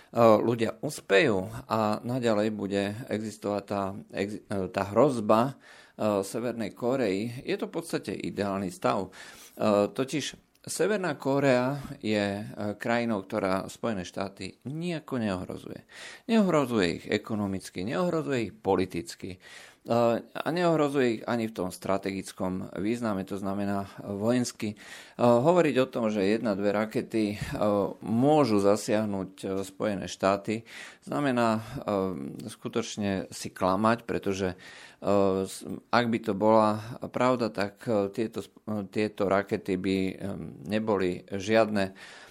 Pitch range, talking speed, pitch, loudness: 100-120 Hz, 100 wpm, 105 Hz, -28 LUFS